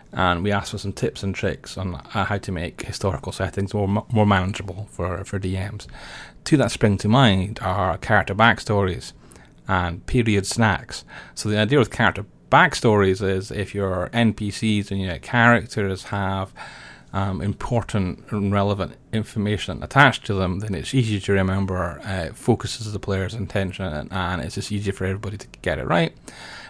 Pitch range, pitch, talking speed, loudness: 95-105 Hz, 100 Hz, 165 wpm, -22 LUFS